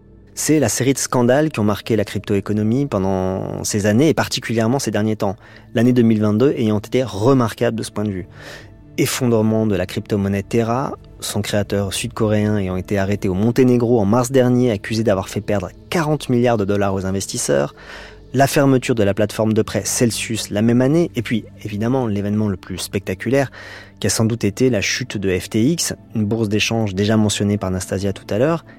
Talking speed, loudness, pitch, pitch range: 190 wpm, -18 LUFS, 110 Hz, 100-120 Hz